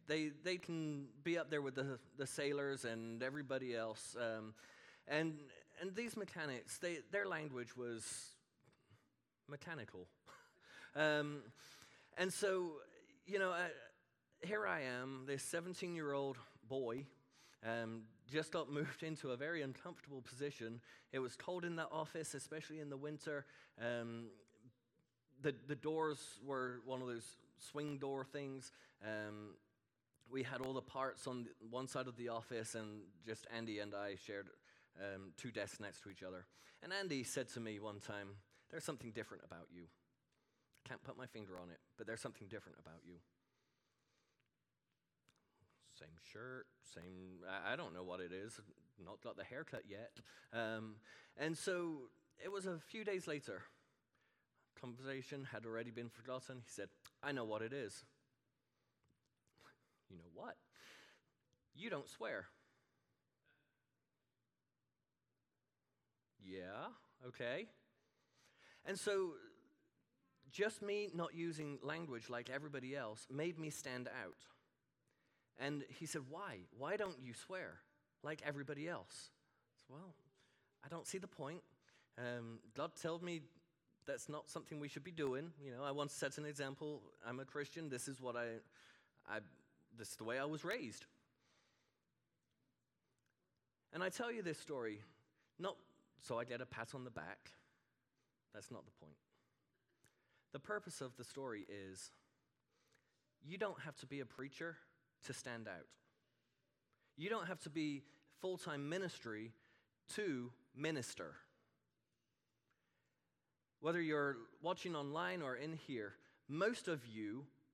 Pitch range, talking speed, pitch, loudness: 115-155 Hz, 145 wpm, 135 Hz, -47 LUFS